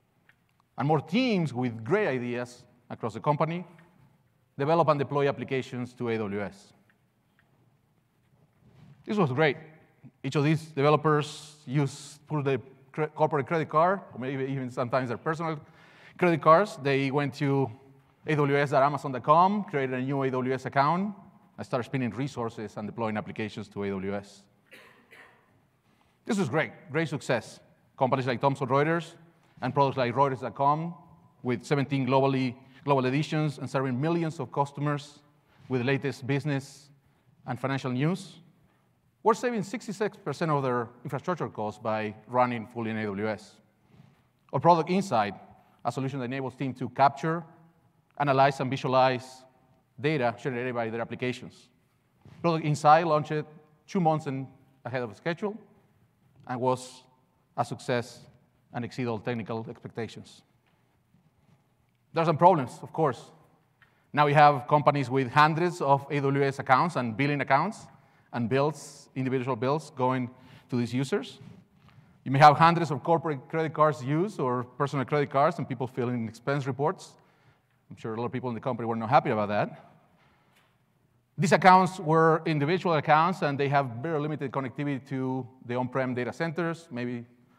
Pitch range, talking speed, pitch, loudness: 125-155 Hz, 140 wpm, 140 Hz, -27 LUFS